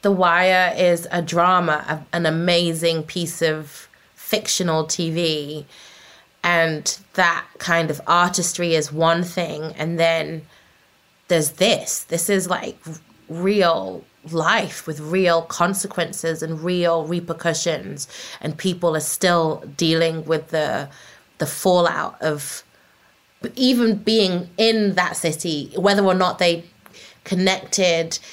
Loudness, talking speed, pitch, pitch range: -20 LUFS, 115 wpm, 170 Hz, 160-185 Hz